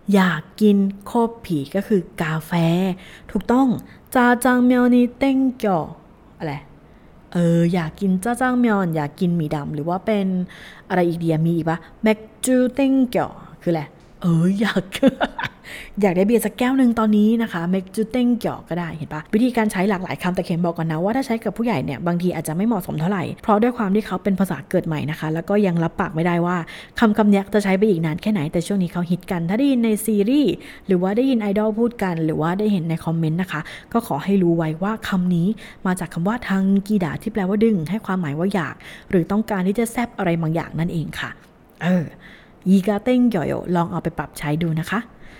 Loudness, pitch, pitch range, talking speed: -20 LUFS, 190 Hz, 170-220 Hz, 635 characters per minute